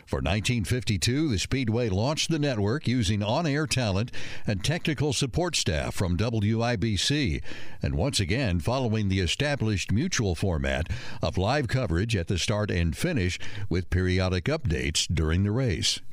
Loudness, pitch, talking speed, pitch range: -27 LUFS, 110 Hz, 145 wpm, 95-130 Hz